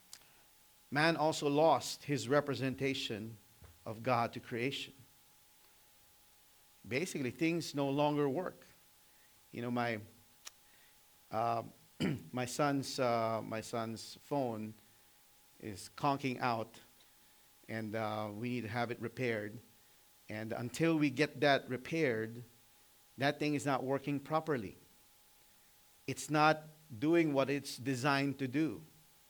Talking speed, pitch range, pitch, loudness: 115 wpm, 115-145 Hz, 125 Hz, -36 LUFS